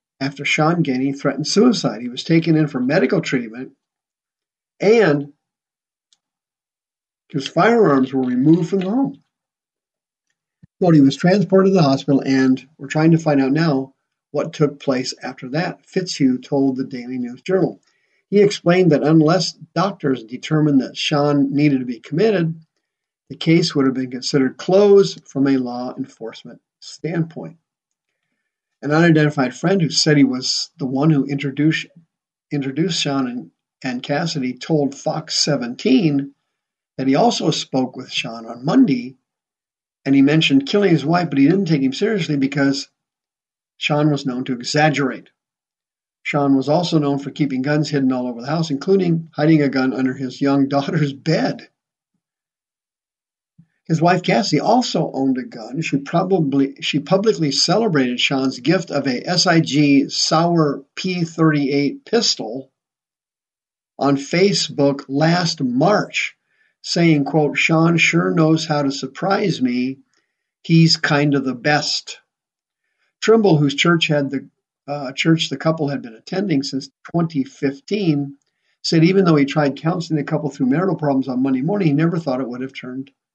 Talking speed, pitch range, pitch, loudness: 150 wpm, 135-165 Hz, 145 Hz, -18 LUFS